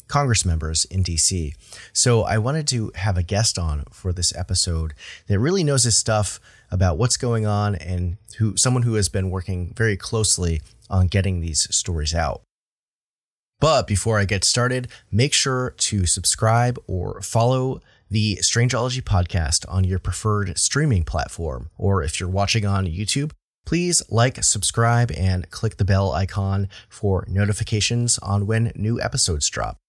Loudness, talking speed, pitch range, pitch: -21 LUFS, 155 wpm, 90-115 Hz, 100 Hz